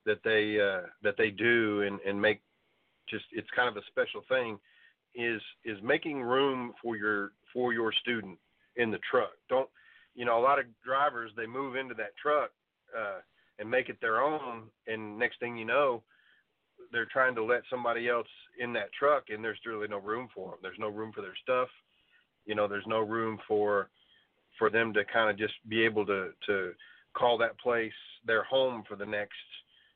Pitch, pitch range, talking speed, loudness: 115 Hz, 105-125 Hz, 195 wpm, -31 LUFS